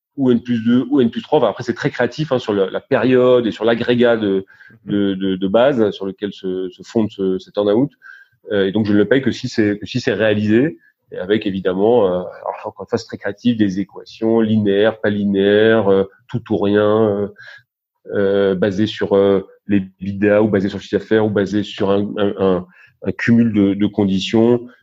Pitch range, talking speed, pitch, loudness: 100-115 Hz, 215 wpm, 105 Hz, -17 LUFS